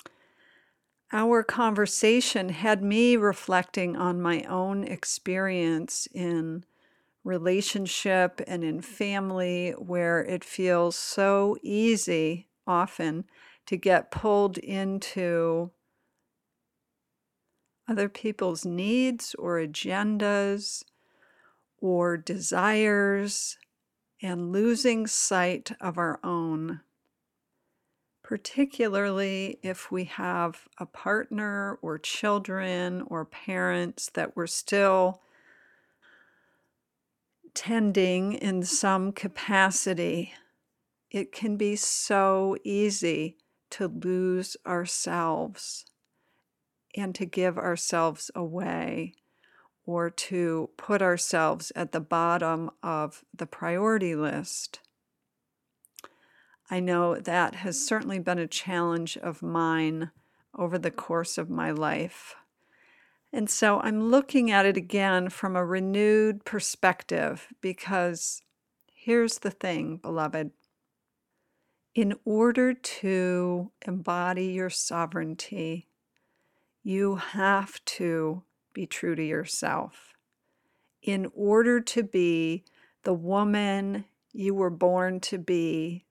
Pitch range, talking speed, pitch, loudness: 175-205 Hz, 95 wpm, 185 Hz, -27 LUFS